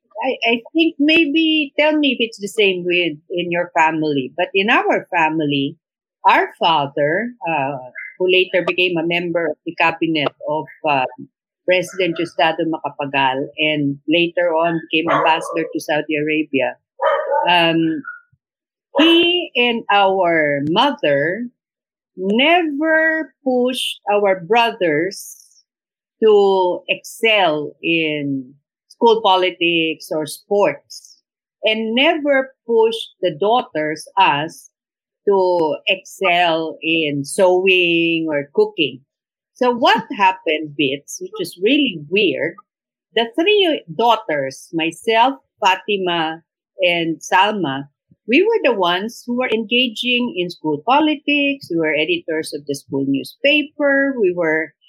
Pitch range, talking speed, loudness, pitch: 160-250 Hz, 115 wpm, -17 LUFS, 180 Hz